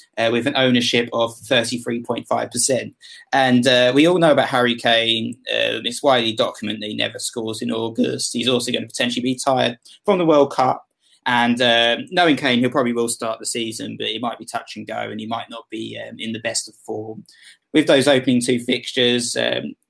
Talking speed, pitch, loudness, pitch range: 215 wpm, 120 Hz, -19 LUFS, 115-125 Hz